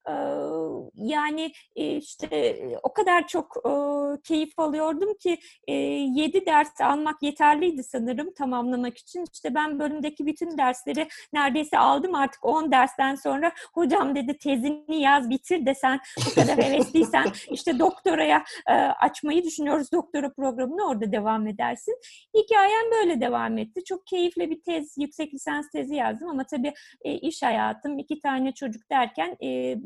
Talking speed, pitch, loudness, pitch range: 130 wpm, 295 Hz, -25 LUFS, 265-340 Hz